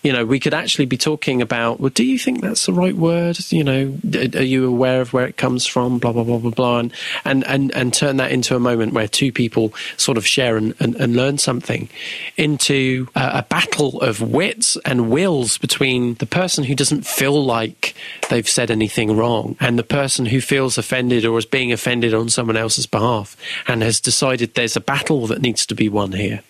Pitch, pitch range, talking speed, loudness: 125 Hz, 120-140 Hz, 215 wpm, -17 LUFS